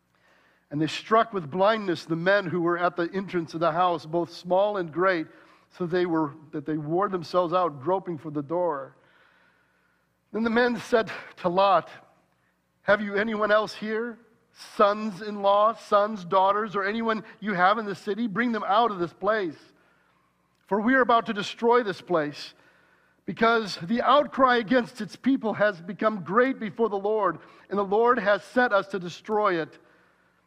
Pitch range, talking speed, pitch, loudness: 175-225 Hz, 175 wpm, 200 Hz, -25 LUFS